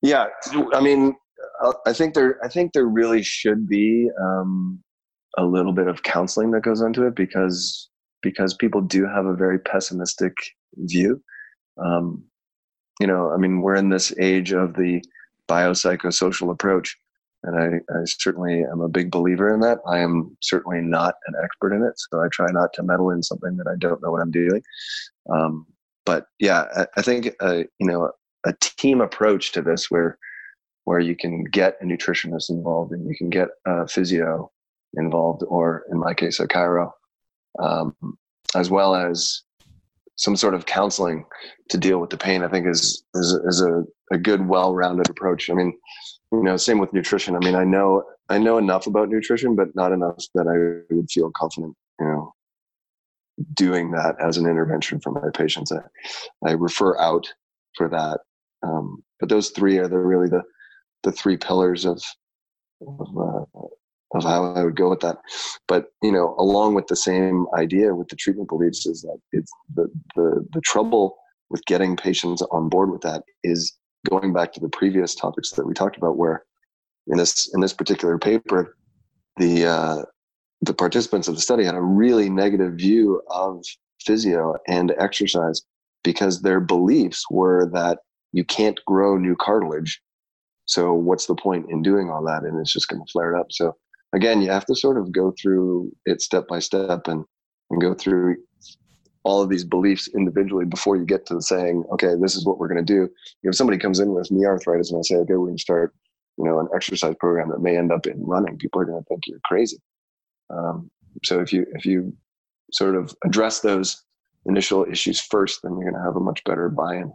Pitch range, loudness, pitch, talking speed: 85-95 Hz, -21 LUFS, 90 Hz, 190 wpm